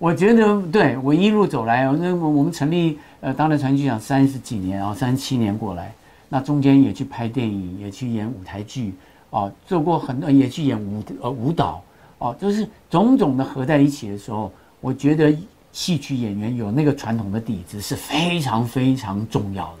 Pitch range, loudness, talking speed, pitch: 105-150 Hz, -20 LUFS, 290 characters per minute, 130 Hz